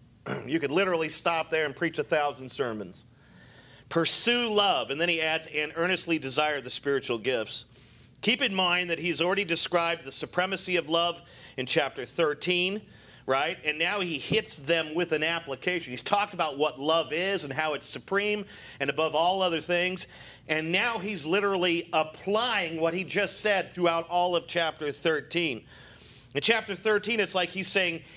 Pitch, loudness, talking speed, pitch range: 165 Hz, -27 LUFS, 175 wpm, 150-185 Hz